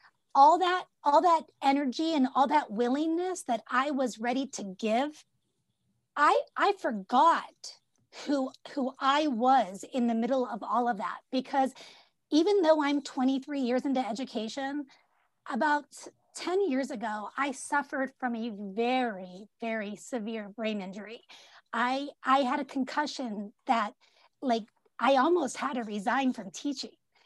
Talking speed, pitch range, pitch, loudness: 140 wpm, 235-290 Hz, 265 Hz, -29 LUFS